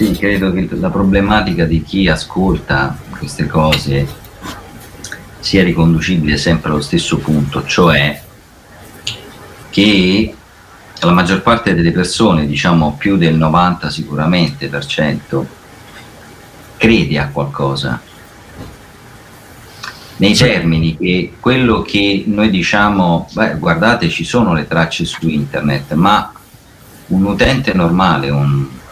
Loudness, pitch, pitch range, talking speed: -13 LUFS, 85 Hz, 75-100 Hz, 110 wpm